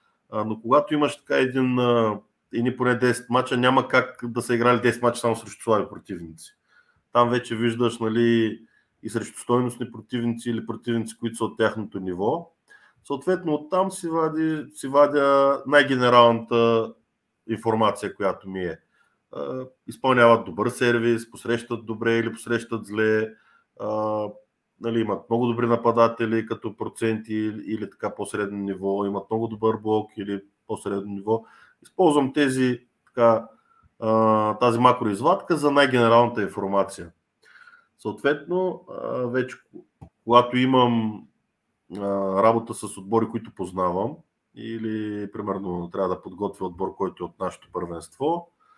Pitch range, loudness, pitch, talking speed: 110-125 Hz, -23 LUFS, 115 Hz, 125 wpm